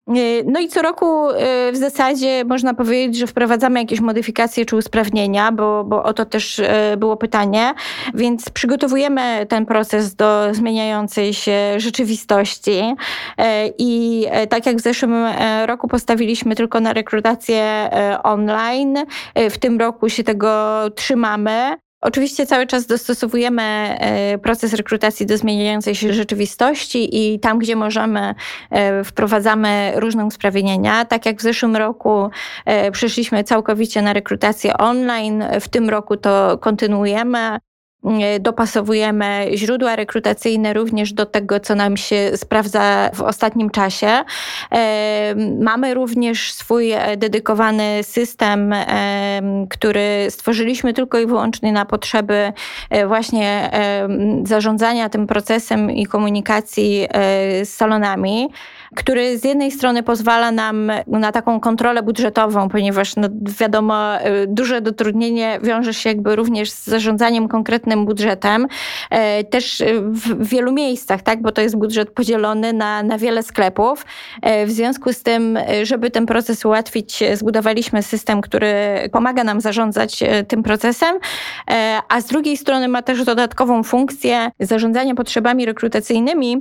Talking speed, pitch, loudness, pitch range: 120 wpm, 225 Hz, -17 LUFS, 210-235 Hz